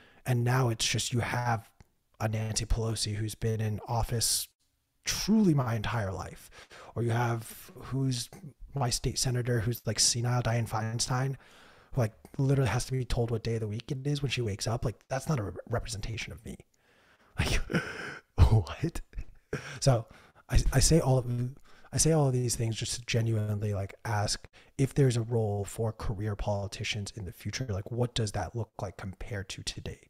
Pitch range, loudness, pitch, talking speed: 105-125 Hz, -31 LUFS, 115 Hz, 185 wpm